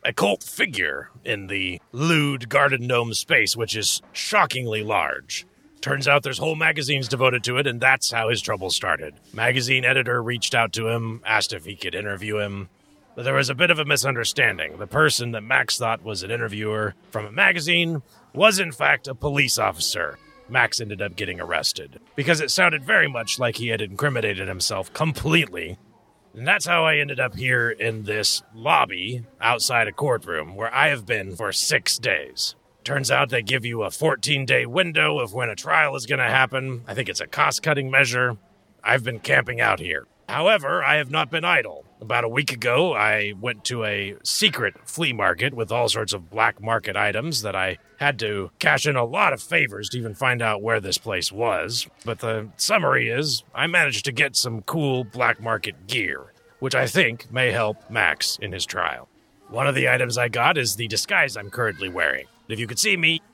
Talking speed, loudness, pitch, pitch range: 200 wpm, -21 LUFS, 120 Hz, 110-135 Hz